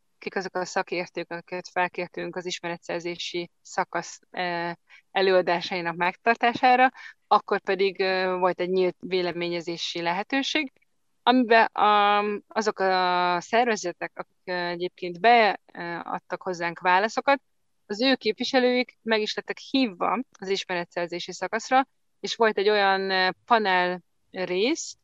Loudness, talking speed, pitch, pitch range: -25 LUFS, 105 wpm, 190 Hz, 180-220 Hz